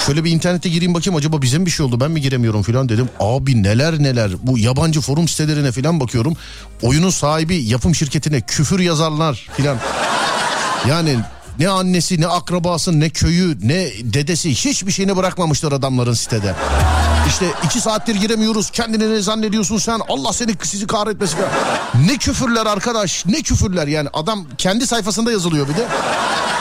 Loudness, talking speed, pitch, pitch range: -16 LUFS, 155 wpm, 160 Hz, 135-190 Hz